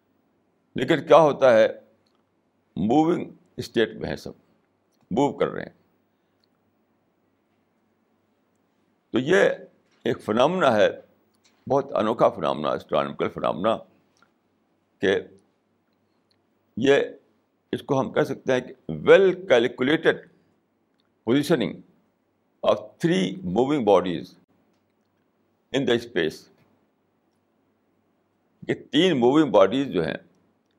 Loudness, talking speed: -22 LUFS, 95 wpm